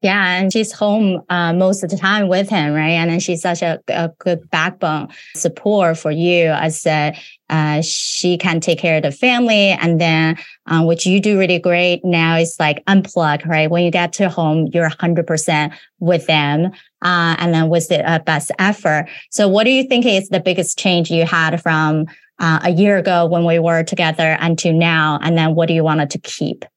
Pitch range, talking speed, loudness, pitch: 160-185 Hz, 210 wpm, -15 LUFS, 170 Hz